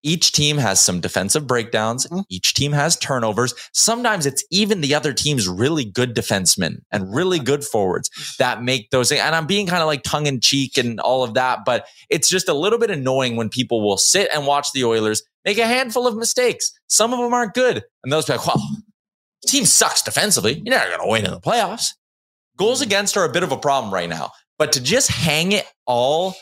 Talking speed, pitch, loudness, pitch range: 220 wpm, 145 Hz, -18 LUFS, 125-195 Hz